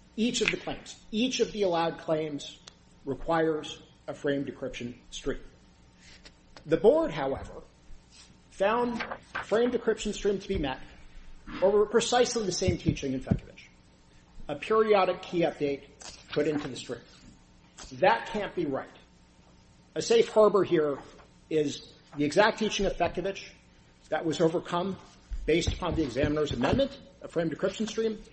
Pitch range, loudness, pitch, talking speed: 125-200 Hz, -29 LUFS, 155 Hz, 140 wpm